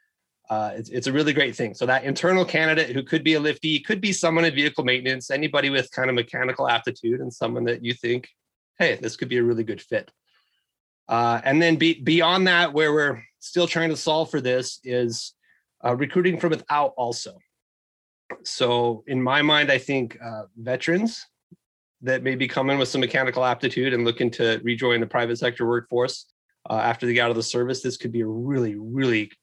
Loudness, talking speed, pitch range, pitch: -23 LUFS, 200 wpm, 120-155 Hz, 130 Hz